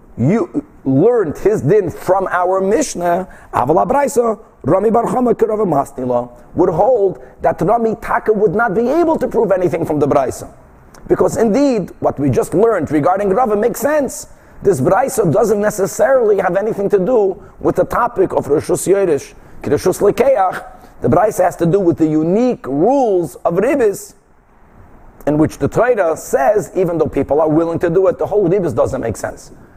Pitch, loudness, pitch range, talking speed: 200 Hz, -15 LUFS, 175-245 Hz, 165 wpm